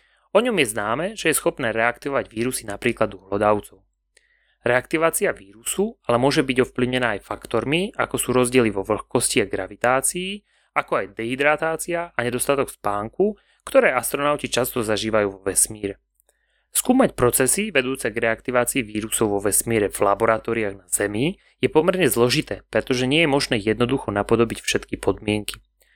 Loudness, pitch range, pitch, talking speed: -21 LUFS, 105-140 Hz, 120 Hz, 145 wpm